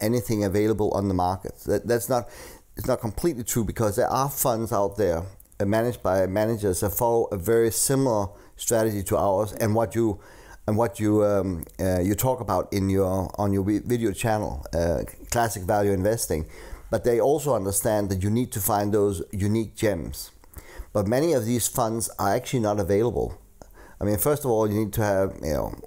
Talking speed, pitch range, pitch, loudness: 190 wpm, 100-115 Hz, 105 Hz, -25 LUFS